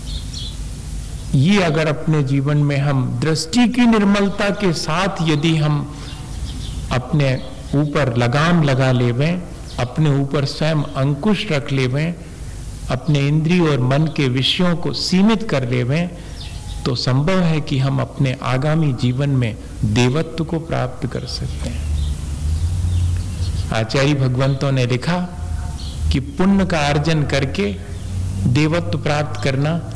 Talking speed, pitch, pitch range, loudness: 120 wpm, 140 Hz, 120-160 Hz, -18 LUFS